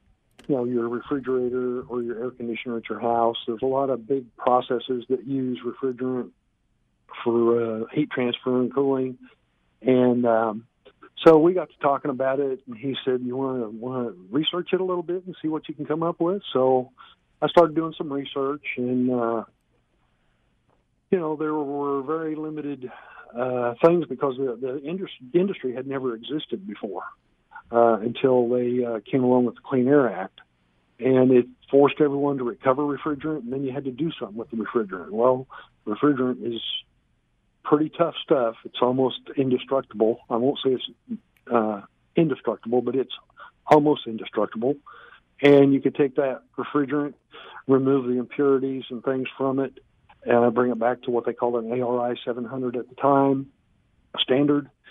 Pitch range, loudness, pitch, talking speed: 120-140 Hz, -24 LUFS, 130 Hz, 170 wpm